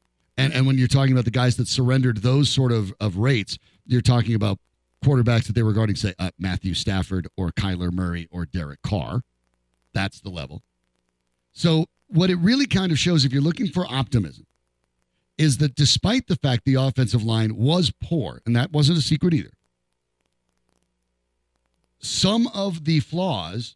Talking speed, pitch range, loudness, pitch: 170 wpm, 85-140 Hz, -22 LUFS, 115 Hz